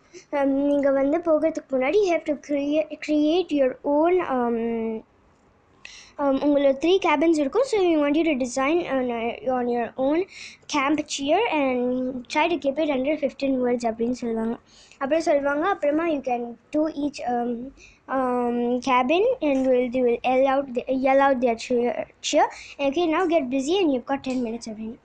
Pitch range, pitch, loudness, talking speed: 250-310 Hz, 275 Hz, -23 LUFS, 140 wpm